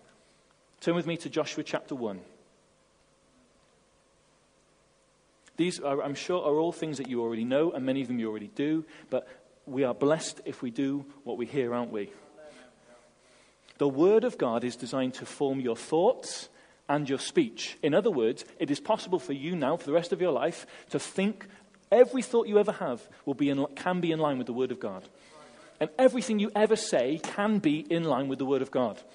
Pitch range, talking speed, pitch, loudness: 135-185 Hz, 200 wpm, 150 Hz, -29 LUFS